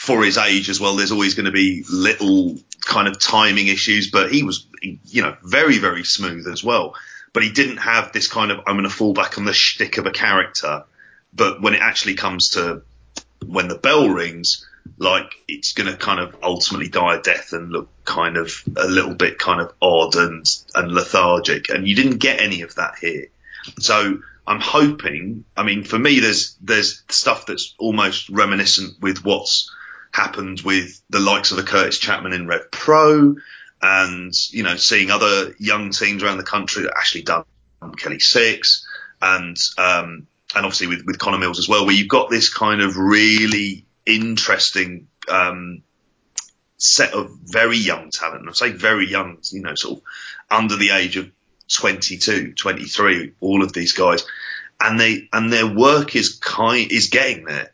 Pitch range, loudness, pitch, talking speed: 90-110 Hz, -17 LUFS, 100 Hz, 185 wpm